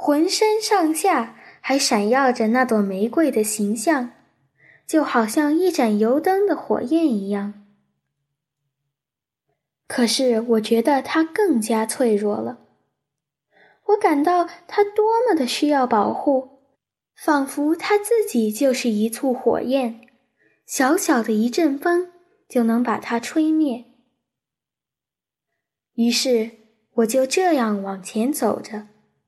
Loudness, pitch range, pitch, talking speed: -20 LUFS, 220-315 Hz, 255 Hz, 170 characters per minute